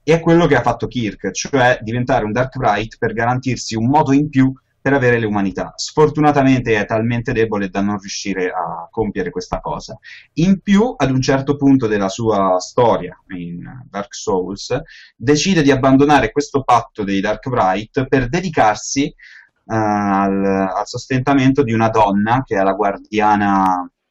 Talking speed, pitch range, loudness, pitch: 160 wpm, 100-140 Hz, -16 LUFS, 120 Hz